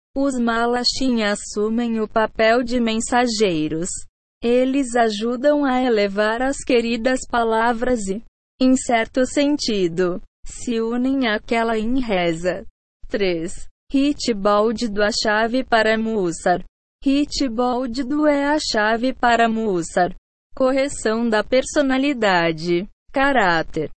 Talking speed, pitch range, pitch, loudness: 105 wpm, 210-260 Hz, 235 Hz, -20 LUFS